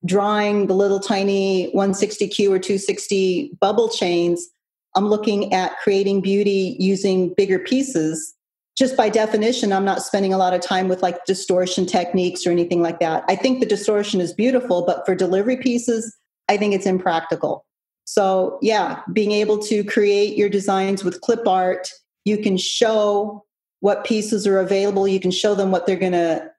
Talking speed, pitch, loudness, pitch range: 170 wpm, 195 Hz, -19 LUFS, 185-210 Hz